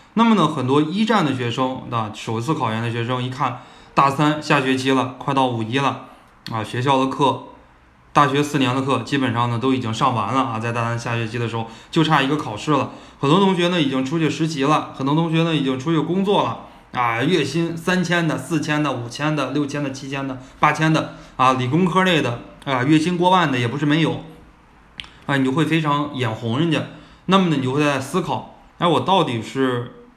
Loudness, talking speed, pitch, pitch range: -20 LUFS, 310 characters per minute, 140 Hz, 130-155 Hz